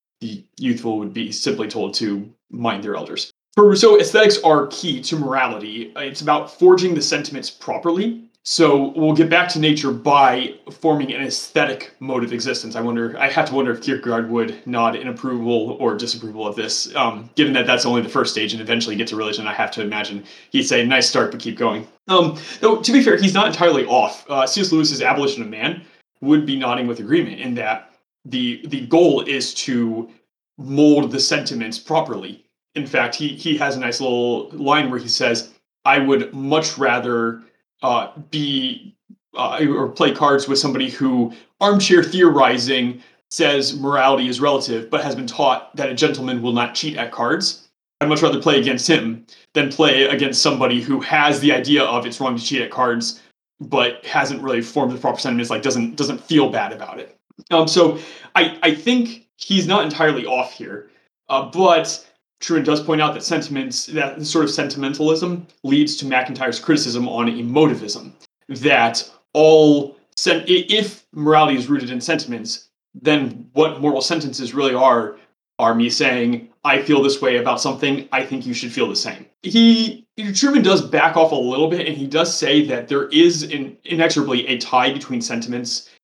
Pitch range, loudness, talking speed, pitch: 125-165 Hz, -18 LUFS, 185 wpm, 140 Hz